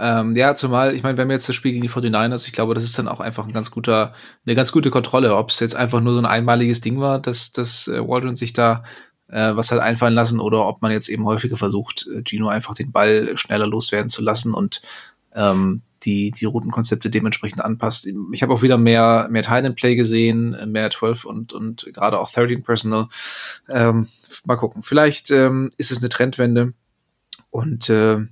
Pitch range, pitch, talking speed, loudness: 110-125 Hz, 115 Hz, 210 wpm, -18 LUFS